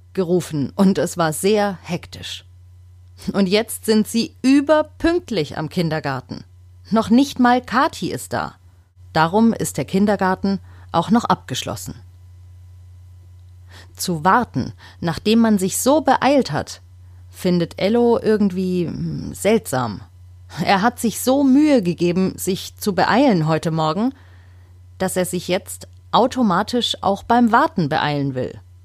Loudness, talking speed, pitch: -19 LUFS, 125 wpm, 175 Hz